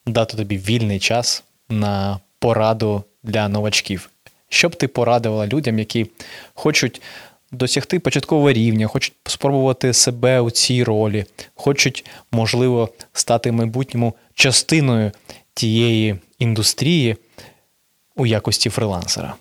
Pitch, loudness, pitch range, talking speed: 115 Hz, -18 LUFS, 110-125 Hz, 105 wpm